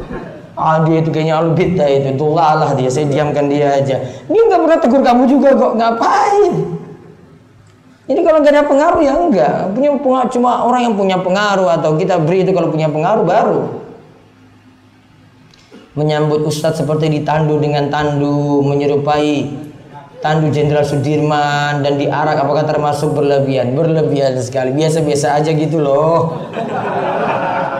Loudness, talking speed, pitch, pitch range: -13 LUFS, 140 wpm, 150 Hz, 145-185 Hz